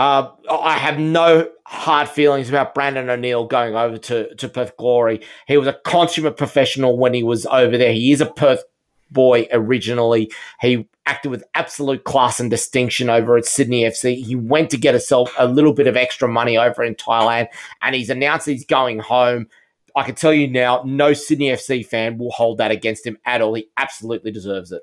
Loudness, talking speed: -17 LUFS, 200 wpm